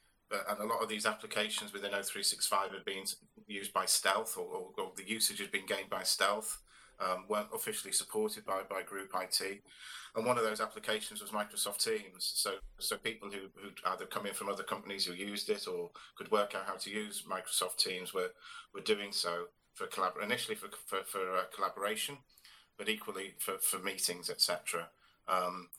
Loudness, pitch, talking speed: -36 LUFS, 115 Hz, 190 wpm